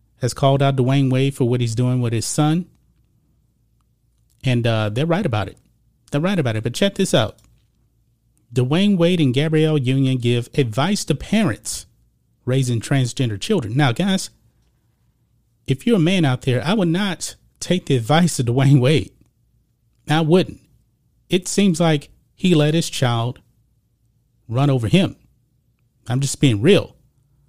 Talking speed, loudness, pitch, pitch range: 155 wpm, -19 LUFS, 135 Hz, 120-155 Hz